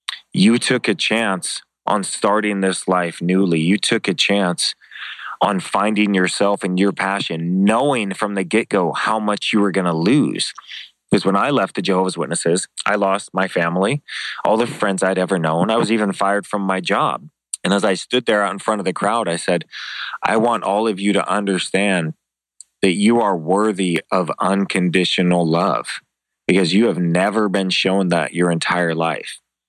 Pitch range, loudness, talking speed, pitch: 90-105 Hz, -18 LUFS, 185 wpm, 95 Hz